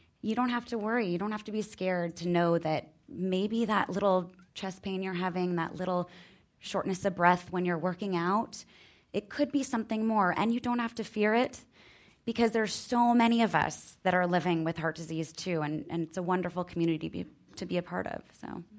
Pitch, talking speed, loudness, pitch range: 185 Hz, 215 wpm, -31 LUFS, 175-220 Hz